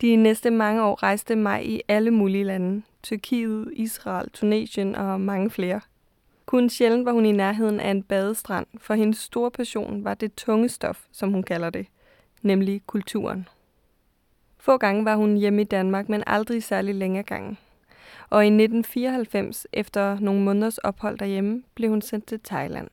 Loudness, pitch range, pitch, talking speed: -24 LUFS, 195-225 Hz, 210 Hz, 170 wpm